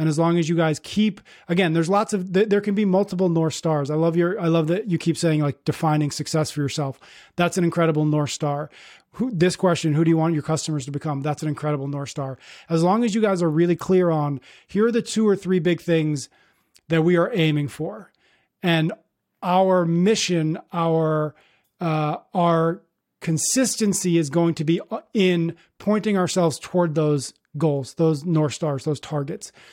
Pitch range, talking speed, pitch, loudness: 155-180 Hz, 195 wpm, 165 Hz, -22 LUFS